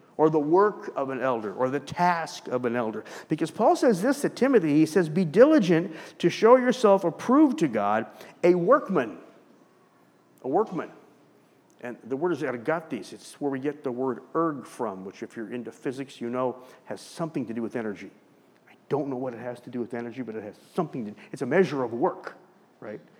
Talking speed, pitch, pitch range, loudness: 205 wpm, 140 Hz, 120-175 Hz, -25 LUFS